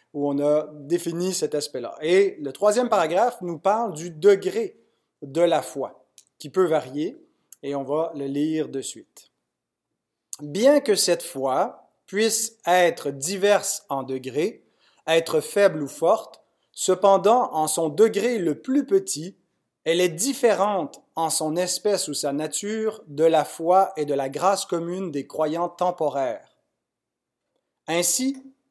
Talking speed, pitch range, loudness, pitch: 140 wpm, 150-205 Hz, -23 LUFS, 175 Hz